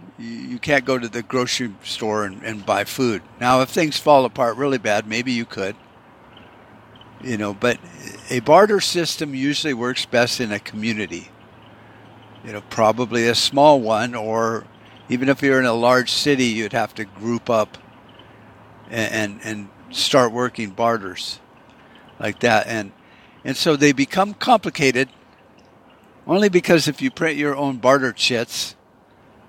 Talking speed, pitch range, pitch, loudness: 155 wpm, 110-140 Hz, 125 Hz, -19 LUFS